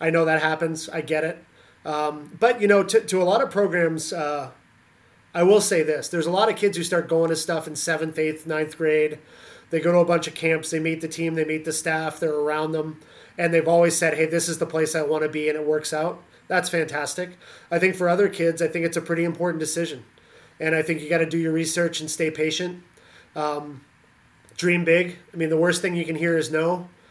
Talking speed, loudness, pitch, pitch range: 245 wpm, -22 LUFS, 165 Hz, 155-170 Hz